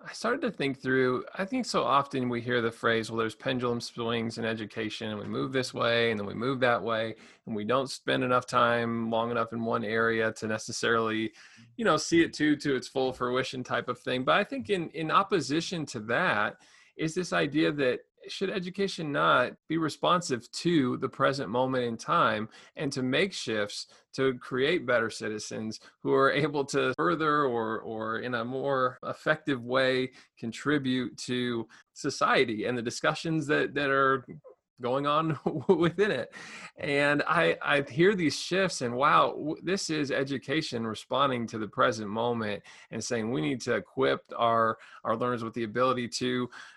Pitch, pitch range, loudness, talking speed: 130 Hz, 115-150 Hz, -29 LUFS, 180 wpm